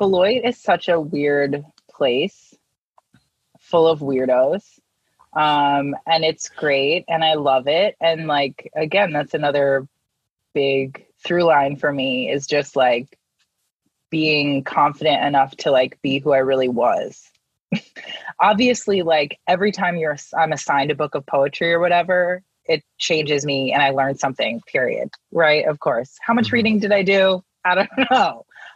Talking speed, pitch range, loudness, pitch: 150 wpm, 140-175 Hz, -19 LUFS, 150 Hz